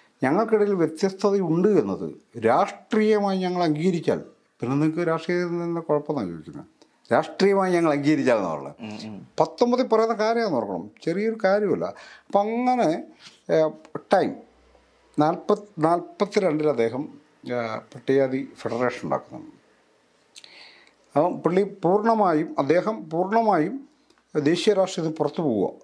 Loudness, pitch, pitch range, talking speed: -23 LUFS, 175 Hz, 155-210 Hz, 100 wpm